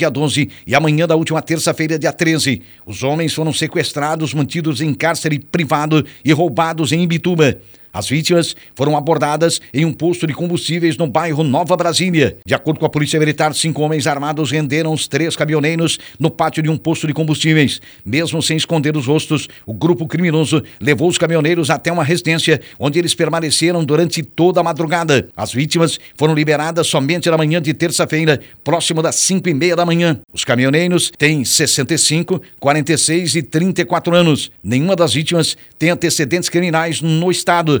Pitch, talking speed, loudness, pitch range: 160 Hz, 170 wpm, -15 LUFS, 150-165 Hz